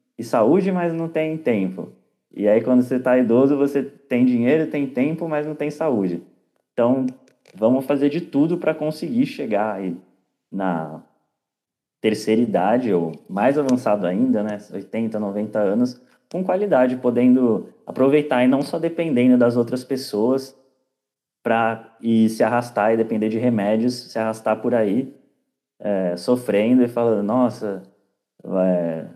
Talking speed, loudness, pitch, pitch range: 145 wpm, -20 LUFS, 125 Hz, 110-140 Hz